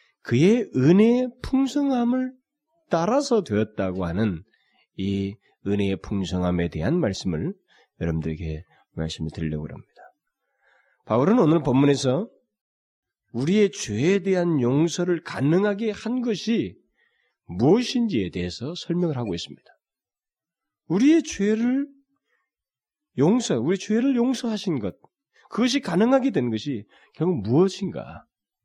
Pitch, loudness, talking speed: 180 Hz, -23 LUFS, 255 characters per minute